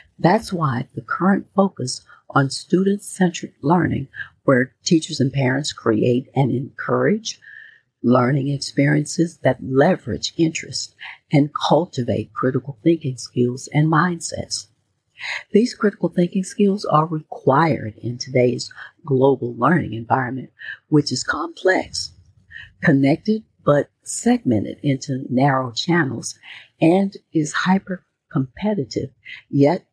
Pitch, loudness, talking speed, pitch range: 145 Hz, -20 LUFS, 105 wpm, 130-175 Hz